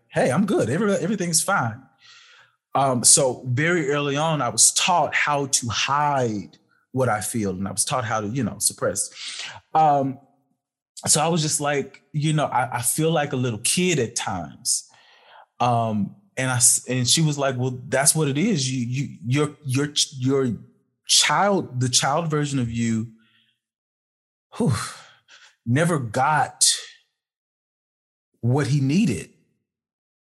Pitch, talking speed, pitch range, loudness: 135 Hz, 150 wpm, 120-155 Hz, -21 LUFS